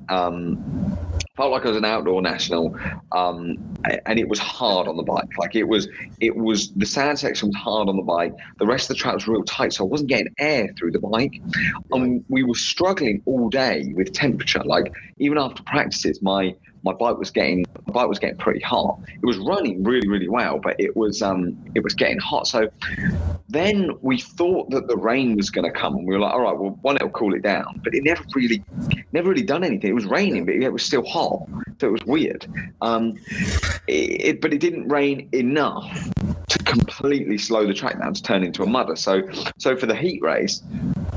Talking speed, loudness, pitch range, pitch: 220 wpm, -22 LUFS, 95-140 Hz, 110 Hz